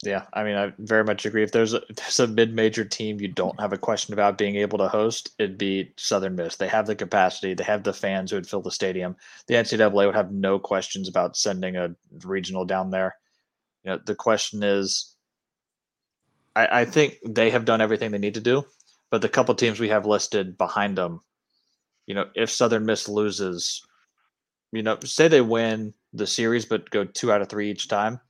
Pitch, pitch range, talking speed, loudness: 105 Hz, 100-110 Hz, 210 wpm, -24 LUFS